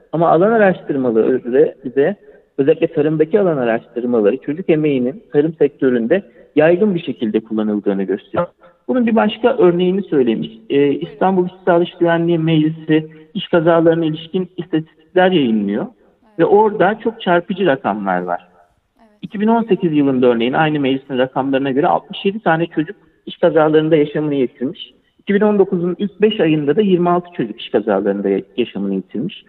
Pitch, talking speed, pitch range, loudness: 160 Hz, 130 wpm, 130-185 Hz, -16 LUFS